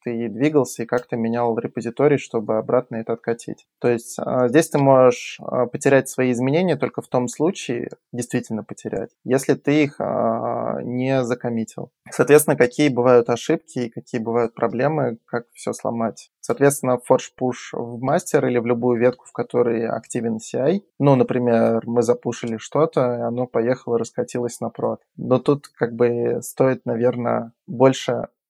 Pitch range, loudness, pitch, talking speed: 120-135 Hz, -21 LUFS, 125 Hz, 155 wpm